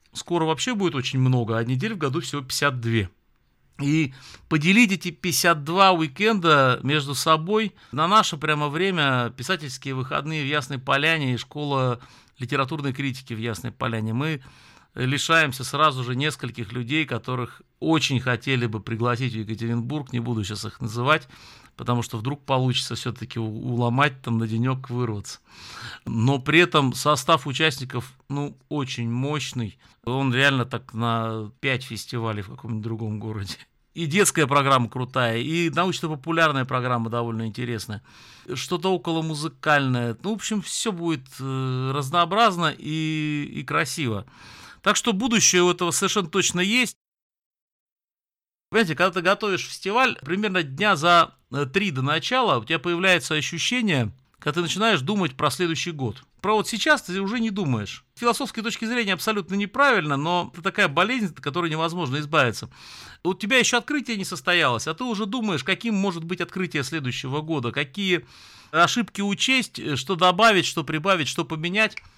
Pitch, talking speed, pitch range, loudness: 150 Hz, 150 wpm, 125-180 Hz, -23 LUFS